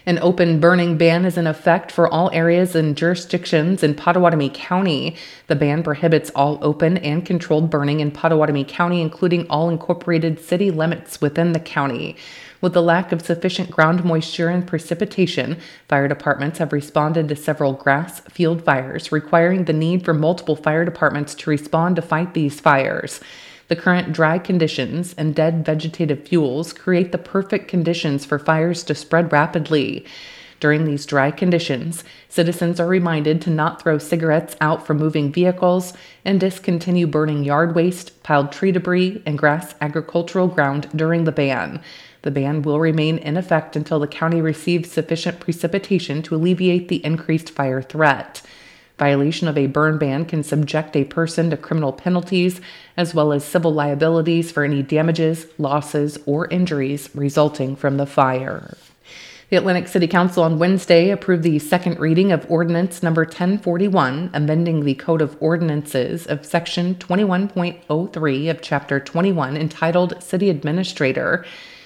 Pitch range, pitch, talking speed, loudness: 150-175 Hz, 165 Hz, 155 wpm, -19 LUFS